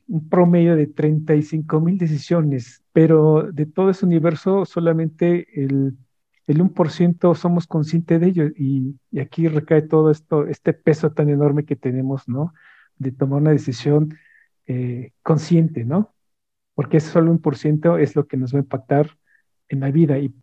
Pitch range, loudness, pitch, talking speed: 140-165 Hz, -19 LUFS, 155 Hz, 160 wpm